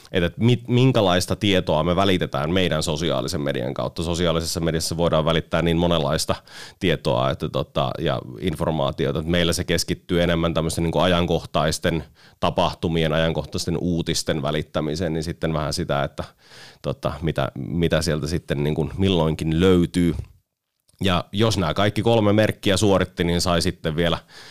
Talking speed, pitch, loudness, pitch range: 140 wpm, 85 Hz, -22 LUFS, 80-90 Hz